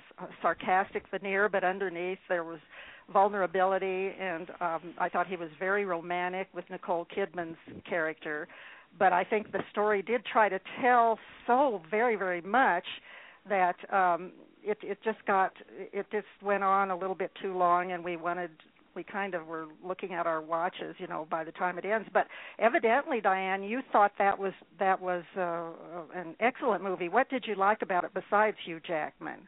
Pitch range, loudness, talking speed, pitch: 175-205 Hz, -30 LUFS, 180 wpm, 190 Hz